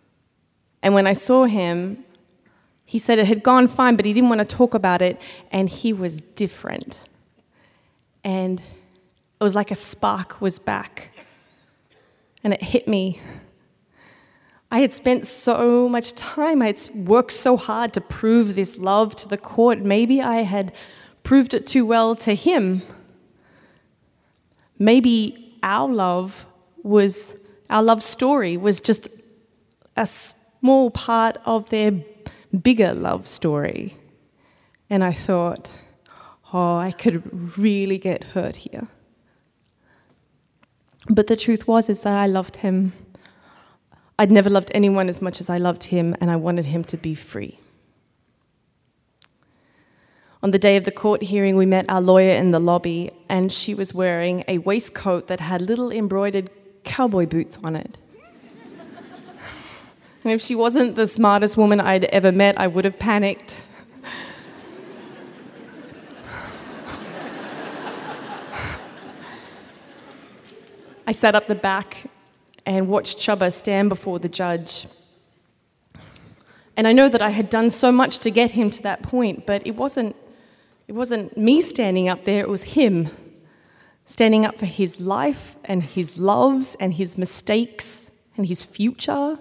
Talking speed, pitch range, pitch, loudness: 140 wpm, 185-230 Hz, 205 Hz, -19 LUFS